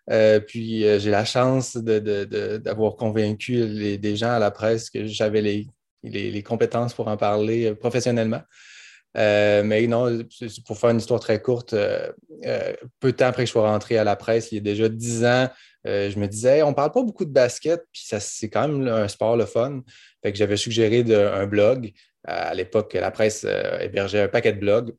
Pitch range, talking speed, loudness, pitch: 105-120 Hz, 220 wpm, -22 LUFS, 115 Hz